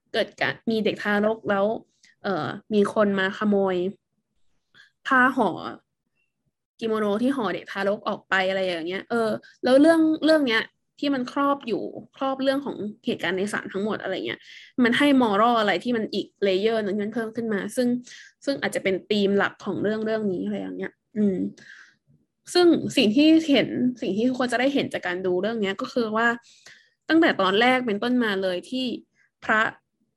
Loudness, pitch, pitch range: -23 LUFS, 225 Hz, 200-255 Hz